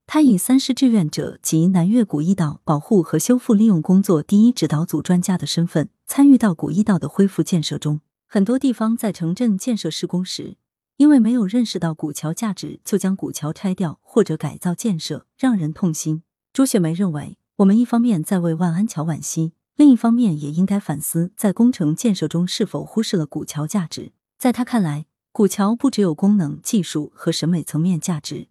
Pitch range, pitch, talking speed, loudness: 160-220 Hz, 185 Hz, 305 characters per minute, -19 LUFS